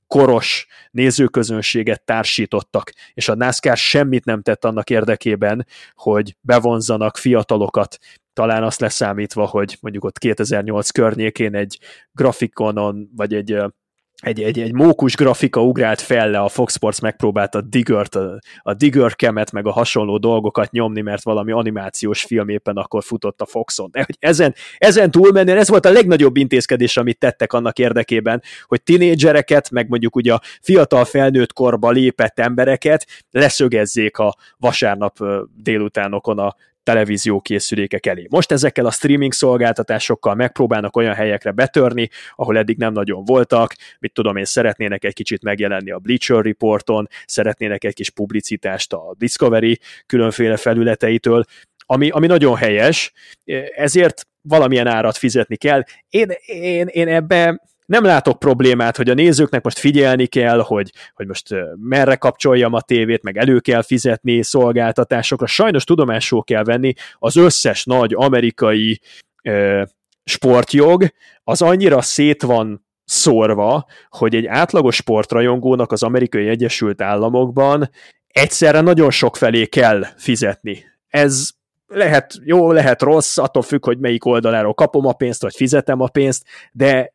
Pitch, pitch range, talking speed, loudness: 120 Hz, 110-135 Hz, 140 wpm, -15 LUFS